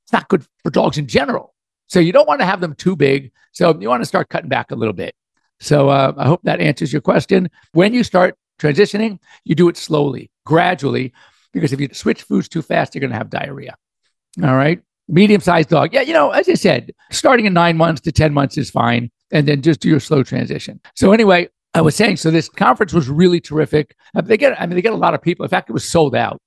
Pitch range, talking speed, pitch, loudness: 145-185 Hz, 250 wpm, 165 Hz, -15 LUFS